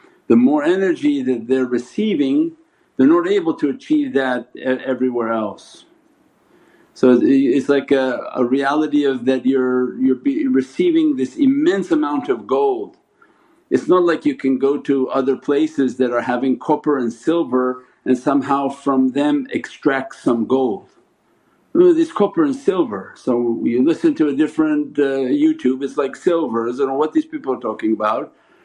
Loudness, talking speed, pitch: -18 LUFS, 160 wpm, 145 Hz